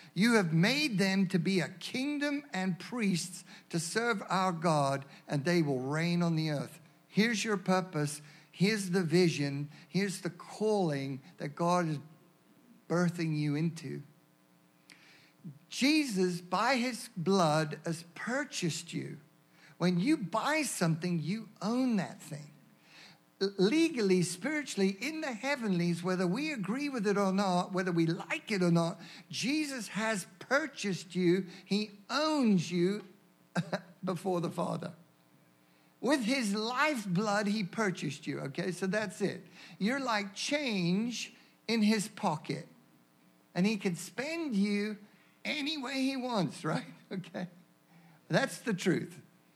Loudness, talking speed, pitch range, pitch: -32 LUFS, 130 wpm, 165-215 Hz, 185 Hz